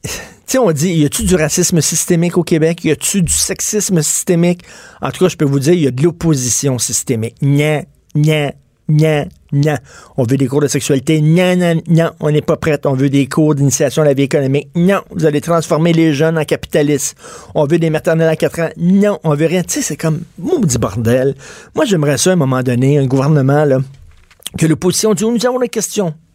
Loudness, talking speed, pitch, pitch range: -13 LUFS, 220 wpm, 155 Hz, 140-175 Hz